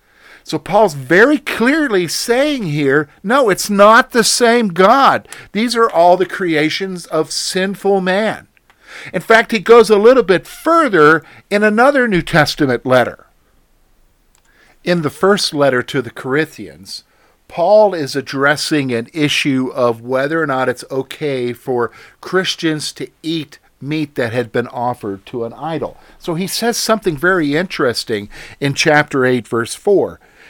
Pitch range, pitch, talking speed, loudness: 135-205 Hz, 160 Hz, 145 wpm, -14 LUFS